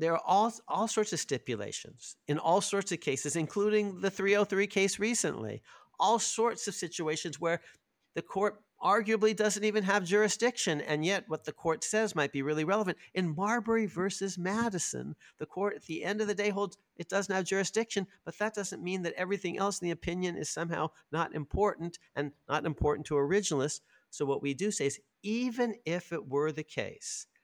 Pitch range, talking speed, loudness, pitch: 160-210 Hz, 190 wpm, -32 LUFS, 190 Hz